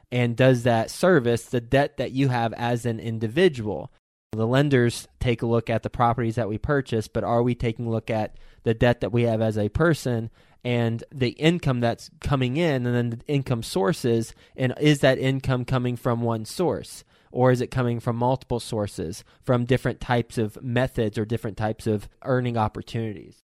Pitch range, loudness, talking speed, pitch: 115-130 Hz, -24 LUFS, 190 wpm, 120 Hz